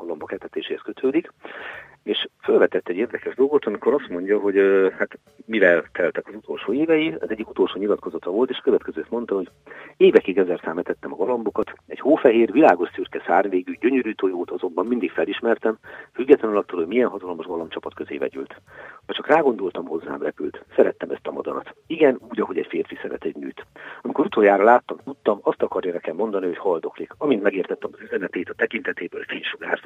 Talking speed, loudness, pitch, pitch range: 165 wpm, -22 LUFS, 400 Hz, 365-435 Hz